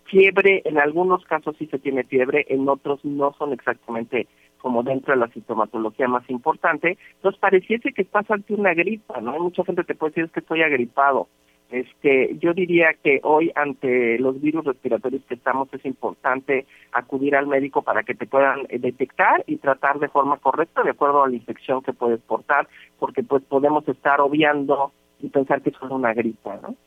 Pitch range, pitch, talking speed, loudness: 125-155 Hz, 140 Hz, 185 wpm, -21 LUFS